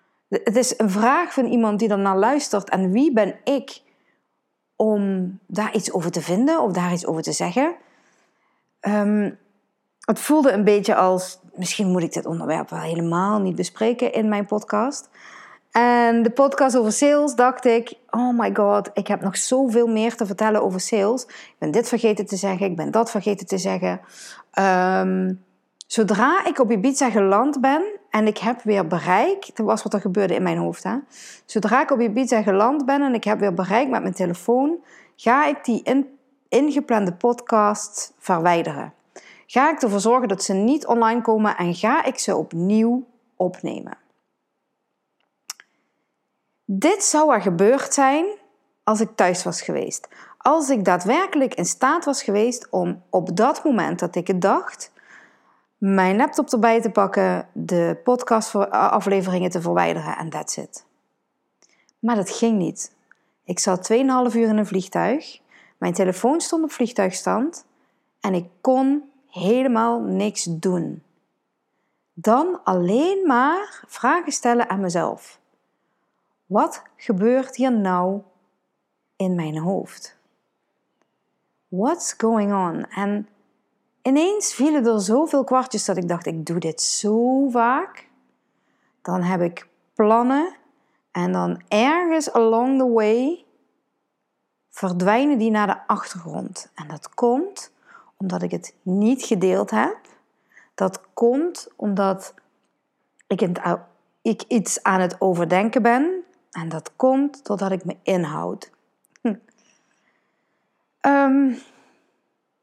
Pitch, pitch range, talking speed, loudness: 220 Hz, 190-260 Hz, 140 wpm, -21 LUFS